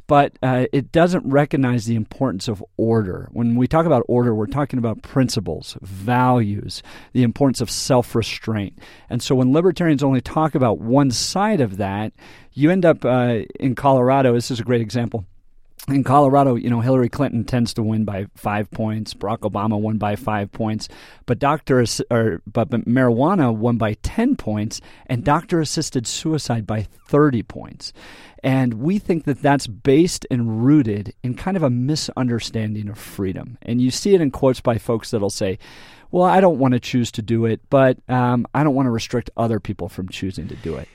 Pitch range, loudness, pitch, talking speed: 110-135 Hz, -19 LUFS, 120 Hz, 185 wpm